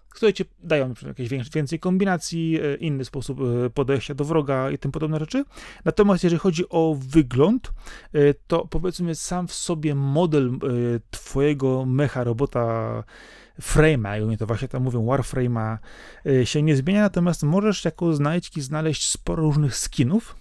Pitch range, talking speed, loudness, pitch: 130-170 Hz, 140 wpm, -23 LUFS, 150 Hz